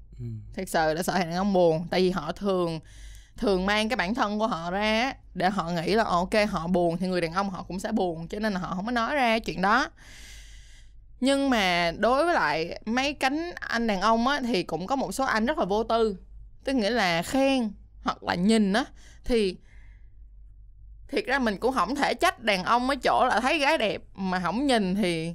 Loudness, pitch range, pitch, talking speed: -26 LUFS, 175-235 Hz, 205 Hz, 220 wpm